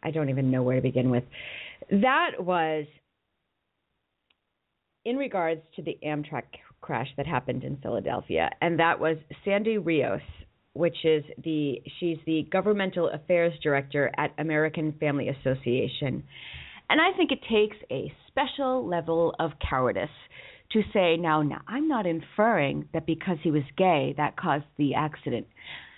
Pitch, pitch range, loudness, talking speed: 160 Hz, 145-180 Hz, -27 LUFS, 145 wpm